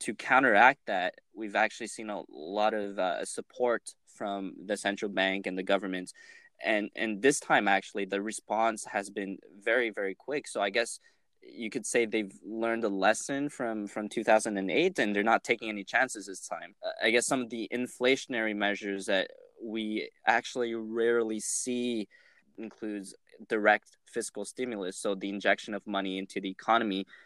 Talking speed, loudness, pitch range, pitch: 165 wpm, -30 LUFS, 100-115 Hz, 110 Hz